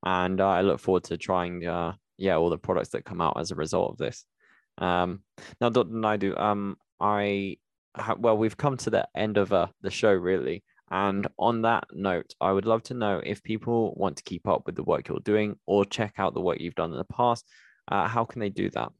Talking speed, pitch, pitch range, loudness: 235 wpm, 100 Hz, 95-110 Hz, -27 LUFS